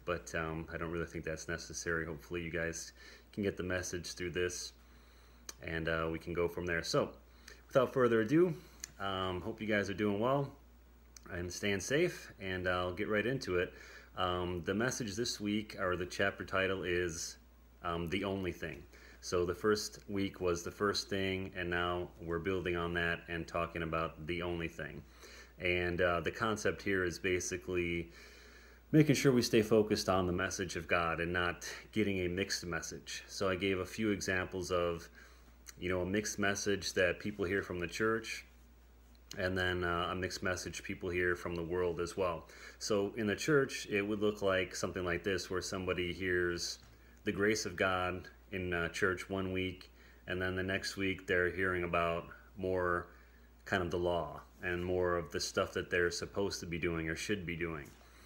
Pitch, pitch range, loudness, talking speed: 90 Hz, 85-95 Hz, -36 LUFS, 185 wpm